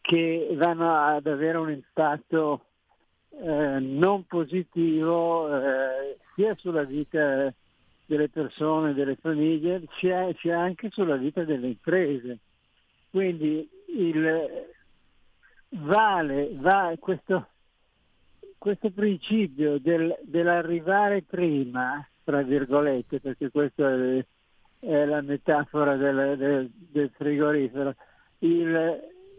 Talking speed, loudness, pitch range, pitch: 100 wpm, -26 LUFS, 140-175 Hz, 155 Hz